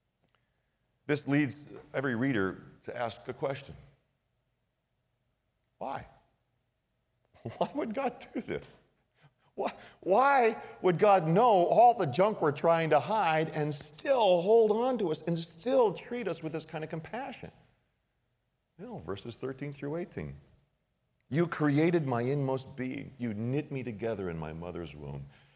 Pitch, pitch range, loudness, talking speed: 145 Hz, 125-170 Hz, -30 LUFS, 145 wpm